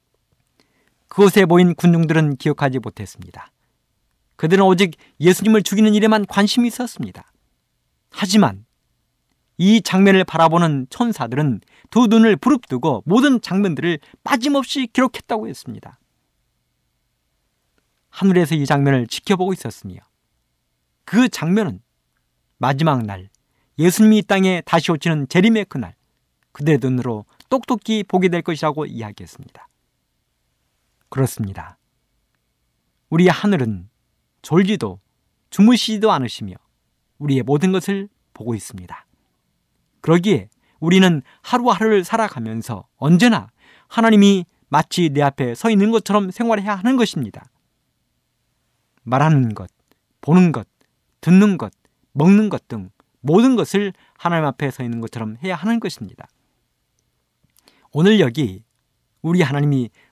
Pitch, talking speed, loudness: 160 Hz, 275 characters per minute, -17 LUFS